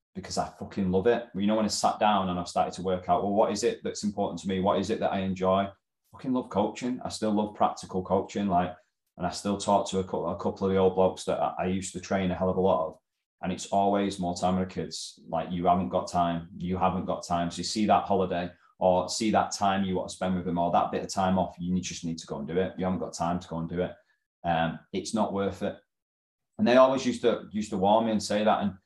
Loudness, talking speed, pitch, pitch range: -28 LUFS, 290 wpm, 95 Hz, 90-100 Hz